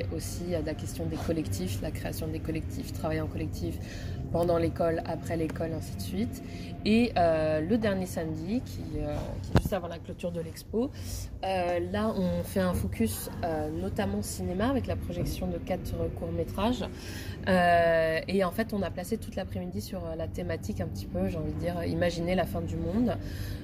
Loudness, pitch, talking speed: -31 LUFS, 100 Hz, 190 wpm